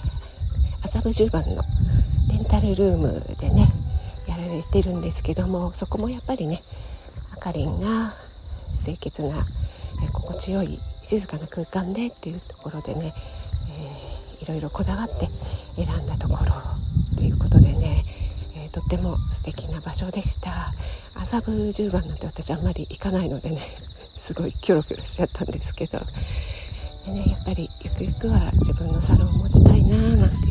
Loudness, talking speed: -24 LUFS, 320 characters per minute